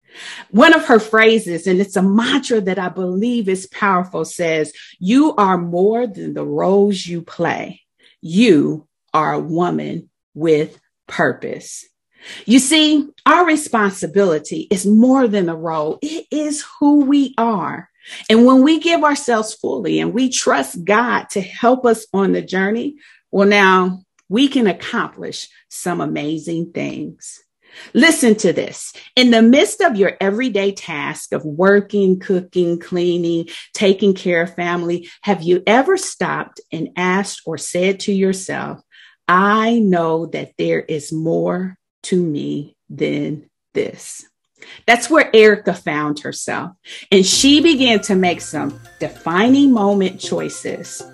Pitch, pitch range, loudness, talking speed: 195 Hz, 175-235 Hz, -16 LUFS, 140 wpm